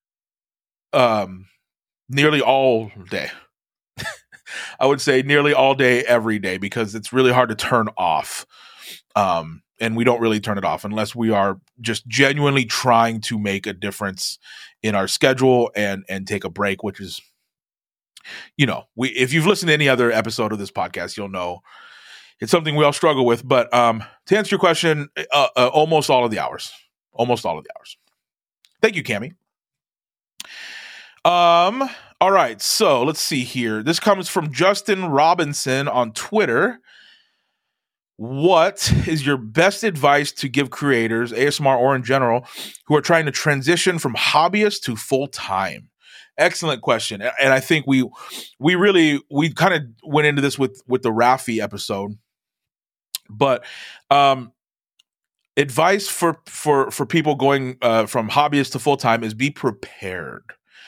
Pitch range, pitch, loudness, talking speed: 115-150 Hz, 135 Hz, -19 LUFS, 160 wpm